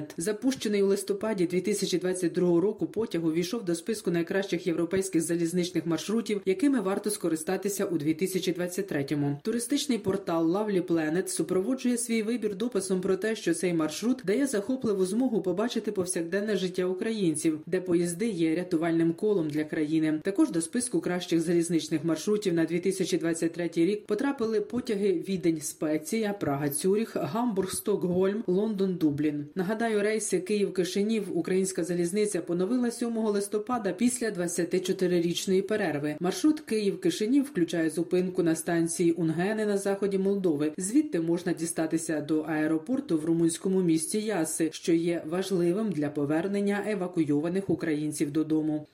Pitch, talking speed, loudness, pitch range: 185 Hz, 125 wpm, -28 LUFS, 165-210 Hz